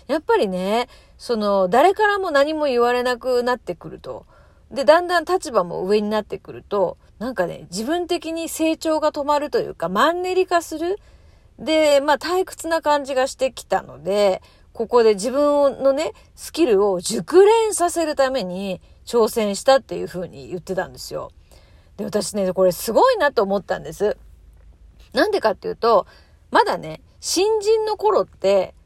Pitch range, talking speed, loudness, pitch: 200-335 Hz, 315 characters per minute, -20 LUFS, 270 Hz